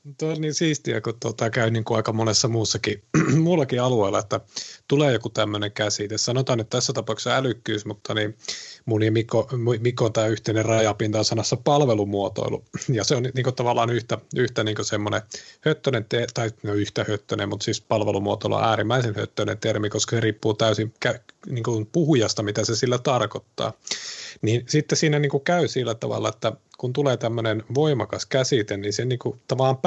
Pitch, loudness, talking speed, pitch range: 115 Hz, -23 LUFS, 170 wpm, 110-130 Hz